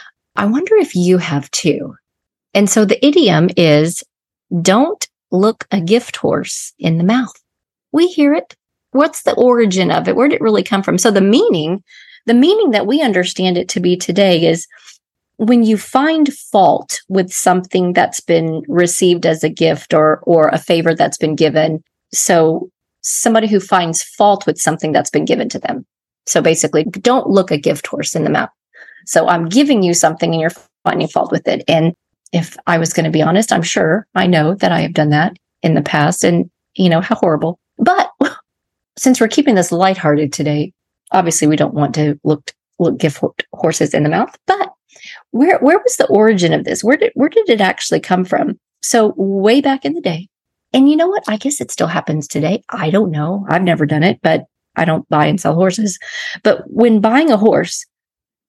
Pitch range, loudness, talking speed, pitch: 165-230 Hz, -14 LUFS, 200 wpm, 185 Hz